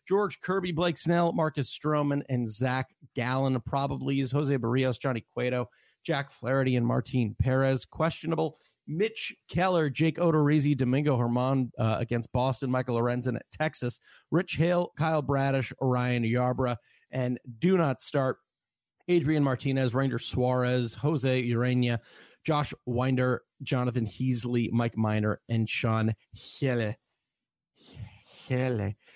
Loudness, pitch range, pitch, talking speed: -28 LUFS, 125-150 Hz, 130 Hz, 125 wpm